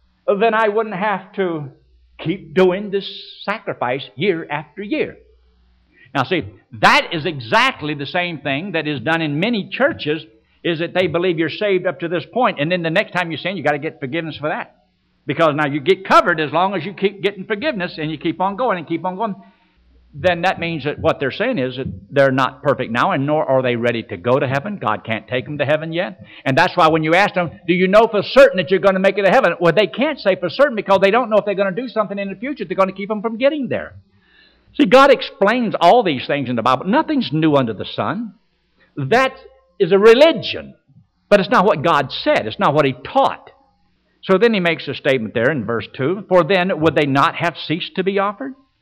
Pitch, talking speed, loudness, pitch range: 180 Hz, 240 wpm, -17 LUFS, 150-200 Hz